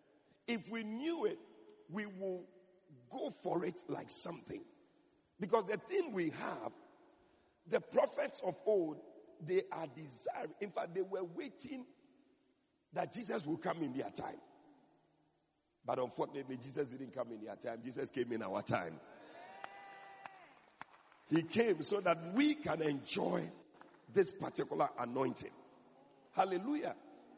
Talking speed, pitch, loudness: 130 wpm, 230 Hz, -40 LUFS